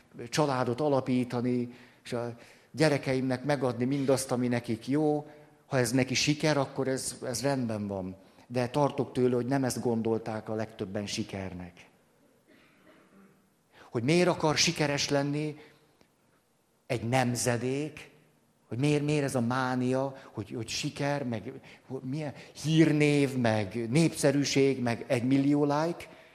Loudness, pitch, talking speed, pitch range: -29 LUFS, 130 Hz, 125 wpm, 120-145 Hz